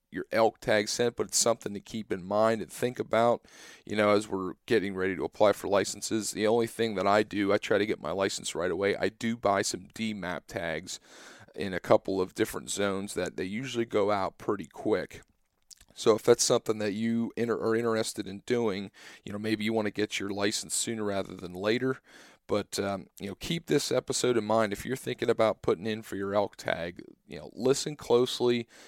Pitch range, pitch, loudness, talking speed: 100-115 Hz, 110 Hz, -29 LUFS, 220 wpm